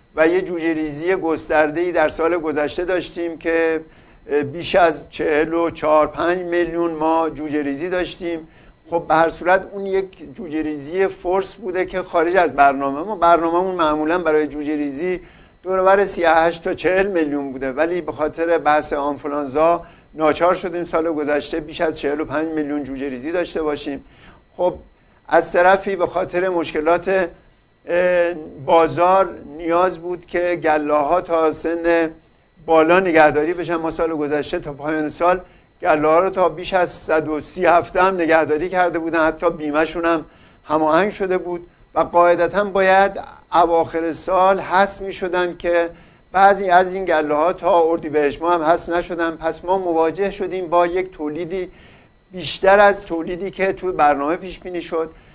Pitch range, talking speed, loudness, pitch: 155-180 Hz, 155 wpm, -19 LUFS, 170 Hz